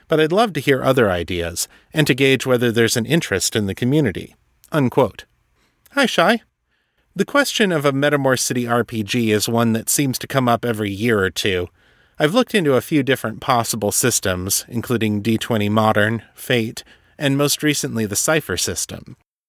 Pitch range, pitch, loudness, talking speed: 110-145 Hz, 120 Hz, -18 LUFS, 170 wpm